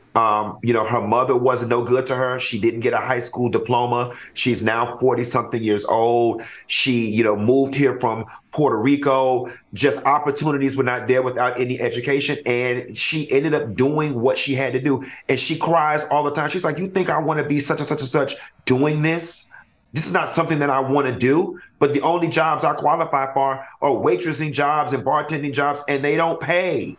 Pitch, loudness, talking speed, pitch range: 135 Hz, -20 LUFS, 215 wpm, 125-150 Hz